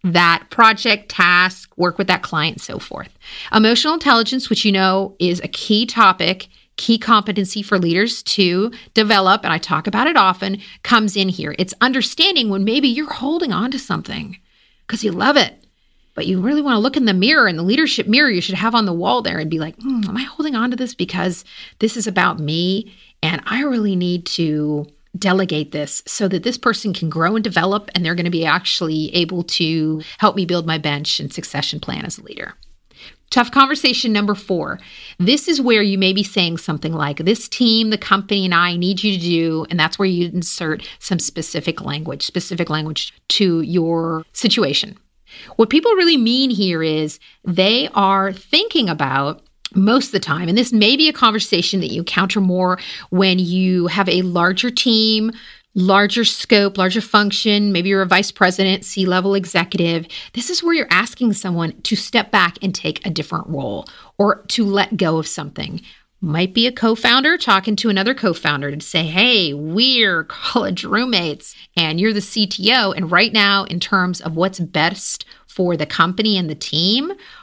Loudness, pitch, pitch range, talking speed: -16 LUFS, 195 Hz, 175-225 Hz, 190 wpm